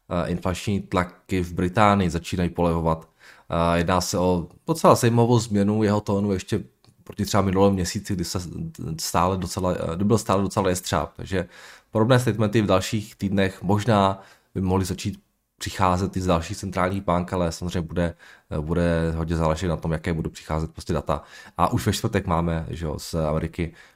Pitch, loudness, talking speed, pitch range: 95 Hz, -24 LUFS, 165 wpm, 85-100 Hz